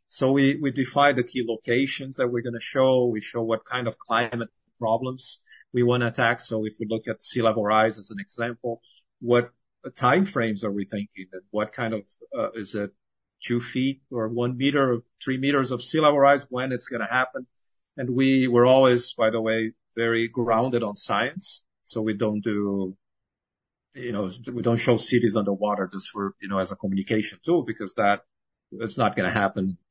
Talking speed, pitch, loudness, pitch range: 205 wpm, 115 Hz, -24 LUFS, 105-125 Hz